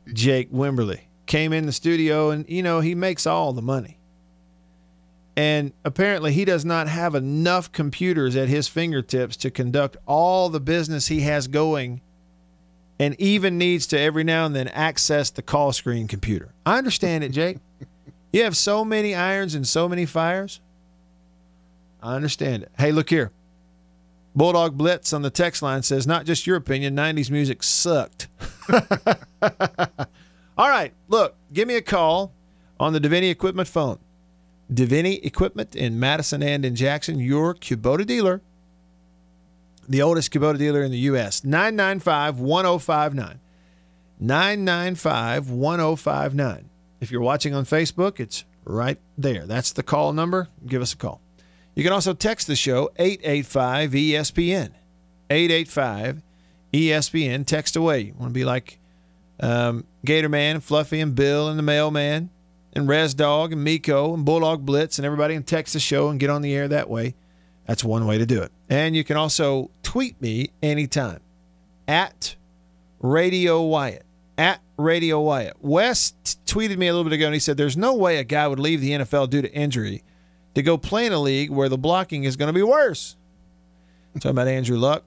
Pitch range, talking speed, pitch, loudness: 120-165 Hz, 165 wpm, 145 Hz, -22 LUFS